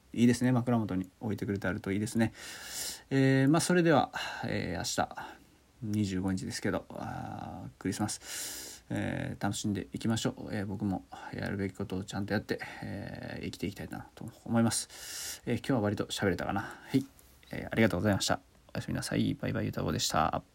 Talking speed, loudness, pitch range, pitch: 410 characters per minute, -32 LUFS, 100-120 Hz, 105 Hz